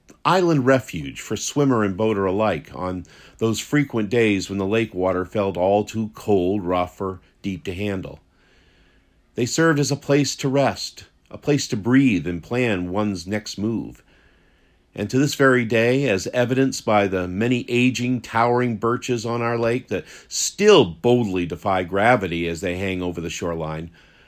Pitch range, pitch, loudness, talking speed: 90-125 Hz, 105 Hz, -21 LUFS, 165 wpm